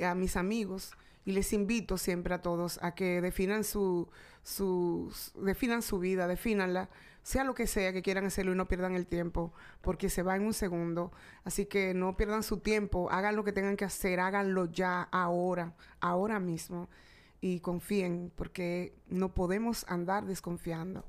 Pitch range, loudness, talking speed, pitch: 180-200 Hz, -34 LUFS, 175 wpm, 185 Hz